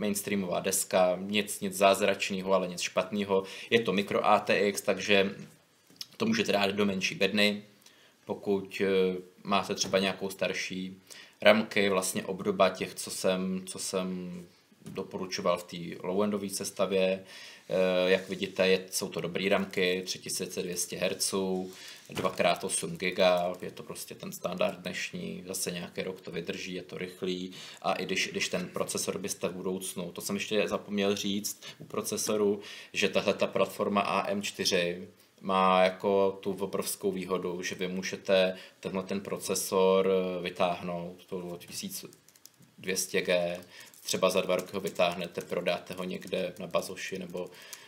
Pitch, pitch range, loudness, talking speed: 95 Hz, 90-100 Hz, -30 LUFS, 140 wpm